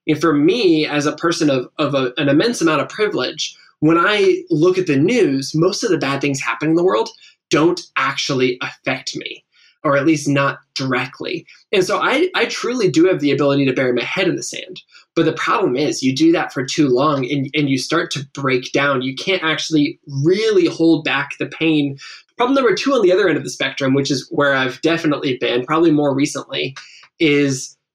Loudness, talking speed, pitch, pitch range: -17 LUFS, 215 wpm, 150 Hz, 140-170 Hz